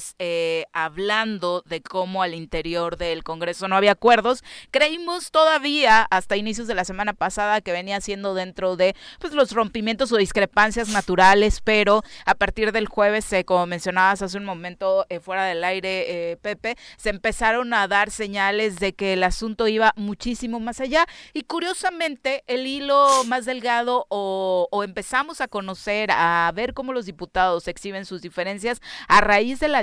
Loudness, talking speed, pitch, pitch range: -21 LUFS, 165 wpm, 205 Hz, 185-235 Hz